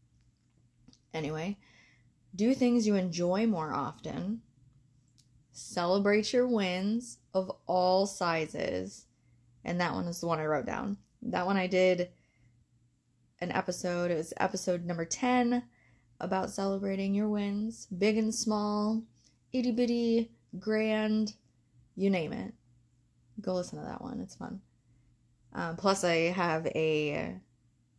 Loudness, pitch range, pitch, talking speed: -31 LUFS, 125-210 Hz, 180 Hz, 125 wpm